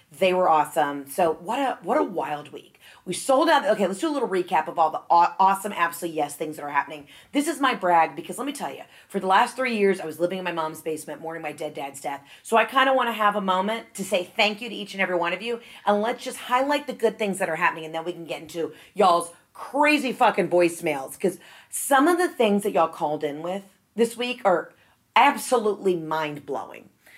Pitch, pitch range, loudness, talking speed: 190 Hz, 160-235 Hz, -24 LUFS, 245 wpm